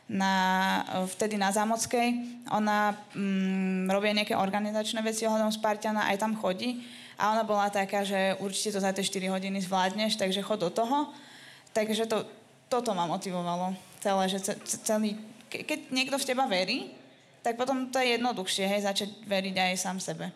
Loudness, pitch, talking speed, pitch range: -29 LUFS, 210 Hz, 165 wpm, 190-225 Hz